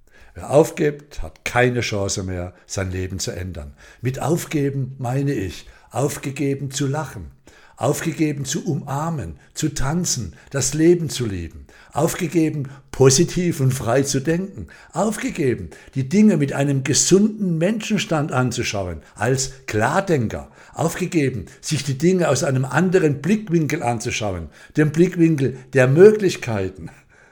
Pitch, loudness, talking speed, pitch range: 140 Hz, -20 LUFS, 120 wpm, 115-165 Hz